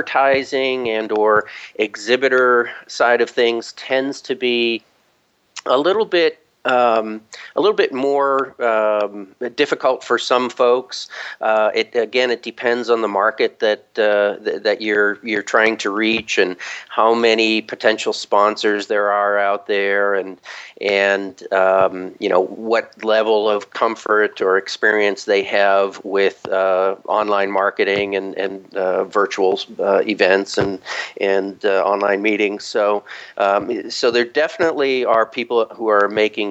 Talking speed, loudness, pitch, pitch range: 145 wpm, -18 LUFS, 110 Hz, 100-120 Hz